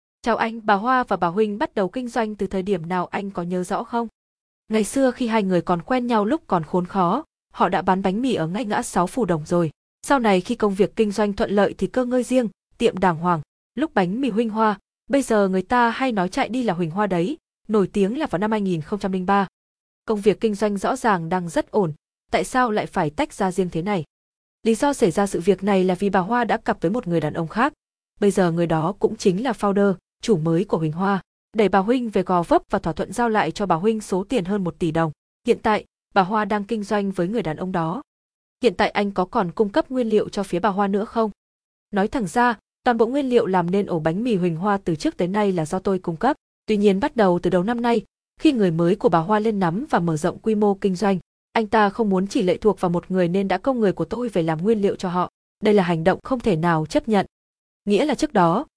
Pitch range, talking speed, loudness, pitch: 185-230 Hz, 265 wpm, -22 LUFS, 205 Hz